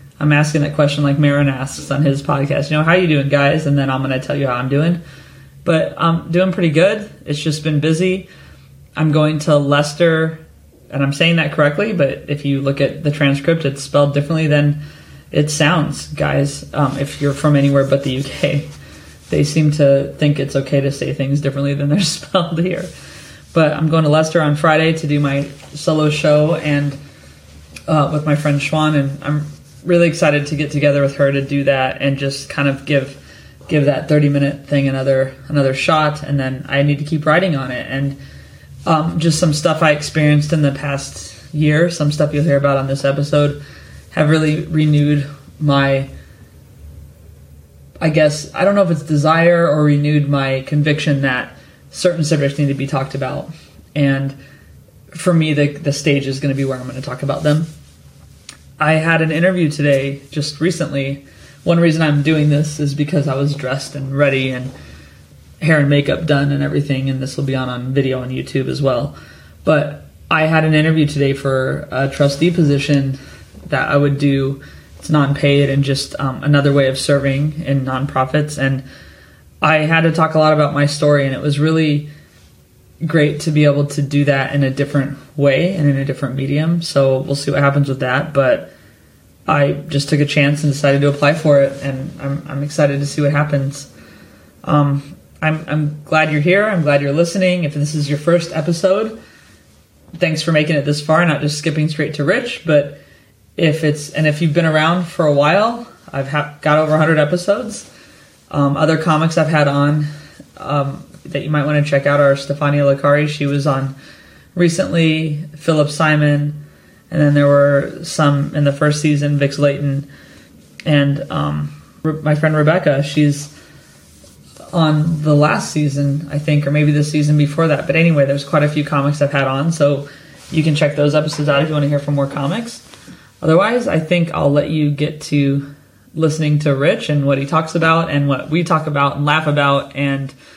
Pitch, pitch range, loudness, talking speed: 145 Hz, 140-155 Hz, -16 LUFS, 195 wpm